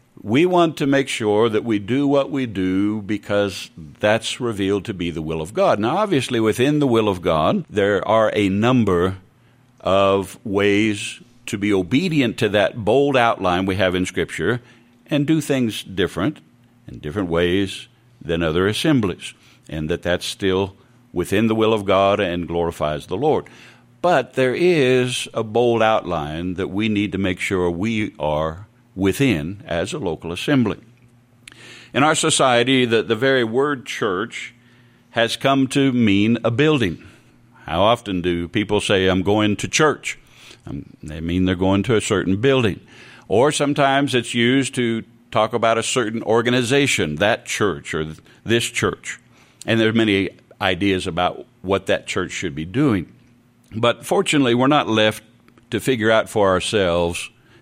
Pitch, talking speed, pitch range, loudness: 110 Hz, 160 wpm, 95-125 Hz, -19 LUFS